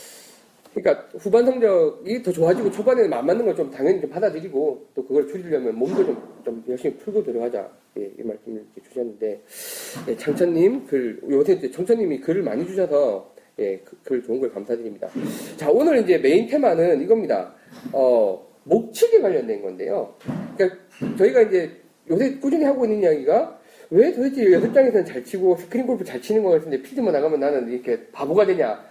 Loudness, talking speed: -21 LUFS, 370 characters per minute